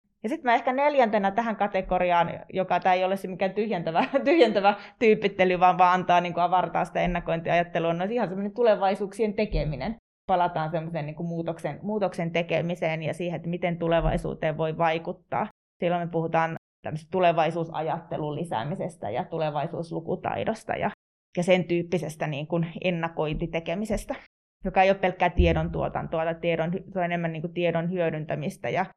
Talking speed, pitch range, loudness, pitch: 145 wpm, 165-195 Hz, -26 LUFS, 175 Hz